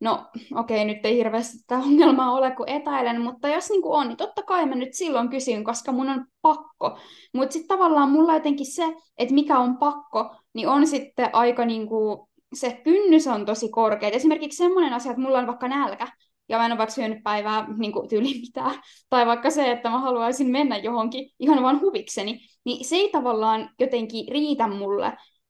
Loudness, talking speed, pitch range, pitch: -23 LUFS, 200 wpm, 230-295 Hz, 260 Hz